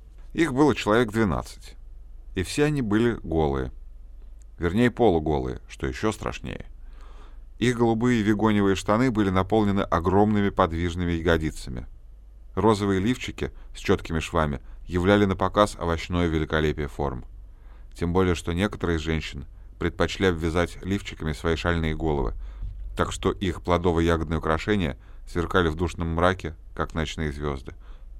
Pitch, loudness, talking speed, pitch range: 85 Hz, -25 LUFS, 125 wpm, 80-100 Hz